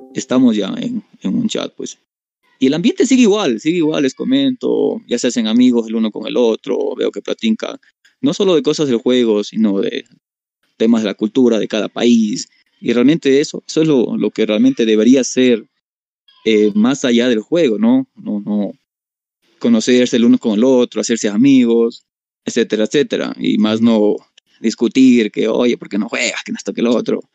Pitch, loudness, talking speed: 125 Hz, -15 LUFS, 190 wpm